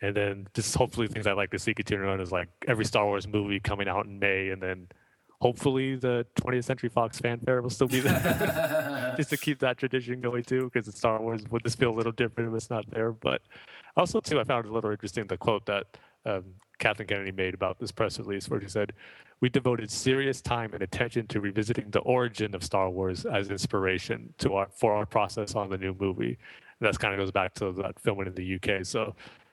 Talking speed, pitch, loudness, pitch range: 230 wpm, 110 Hz, -29 LUFS, 100-125 Hz